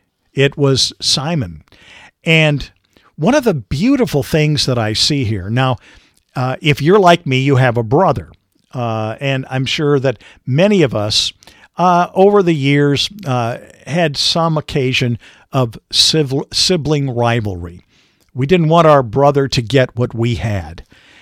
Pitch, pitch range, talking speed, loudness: 135 Hz, 120-155 Hz, 150 wpm, -14 LUFS